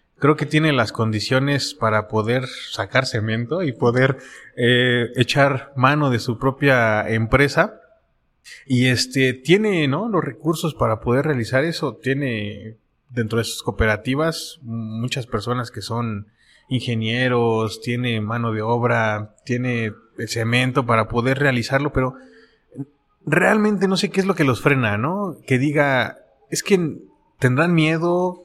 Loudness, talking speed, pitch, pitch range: -20 LUFS, 135 wpm, 130 Hz, 115-145 Hz